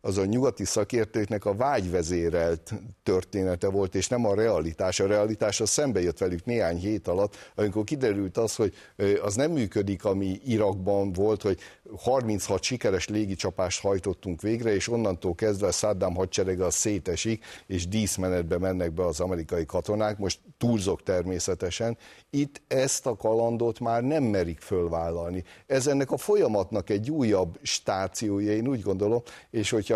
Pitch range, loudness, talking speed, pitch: 95-115 Hz, -27 LUFS, 150 wpm, 105 Hz